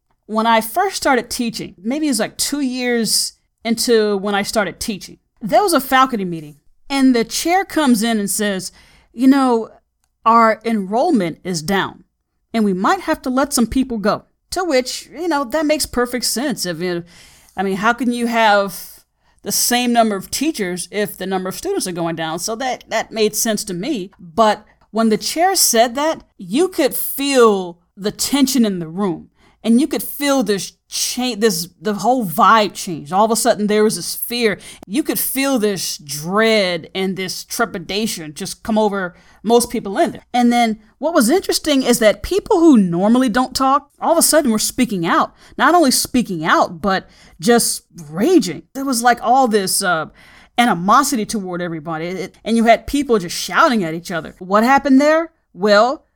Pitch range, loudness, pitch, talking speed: 195-265 Hz, -17 LUFS, 225 Hz, 185 wpm